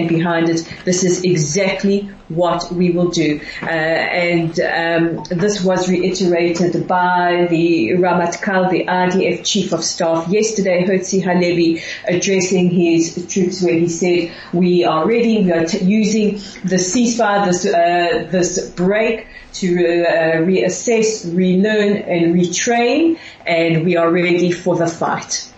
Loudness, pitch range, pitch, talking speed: -16 LUFS, 170-195 Hz, 180 Hz, 140 wpm